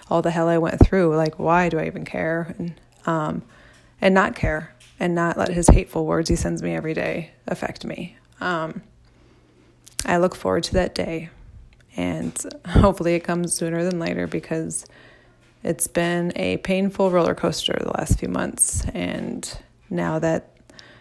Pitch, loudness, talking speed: 165 Hz, -22 LUFS, 165 wpm